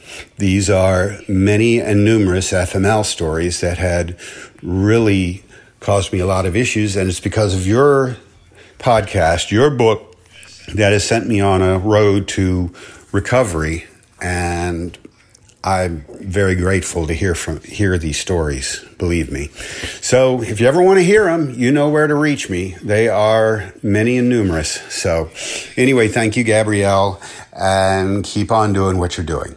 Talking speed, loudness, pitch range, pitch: 155 wpm, -16 LUFS, 90-110 Hz, 100 Hz